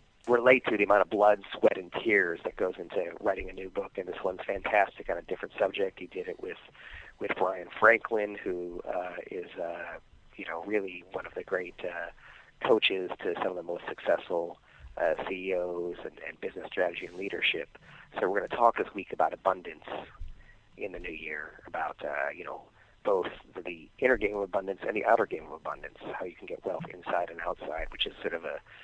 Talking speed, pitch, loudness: 210 wpm, 105 Hz, -31 LUFS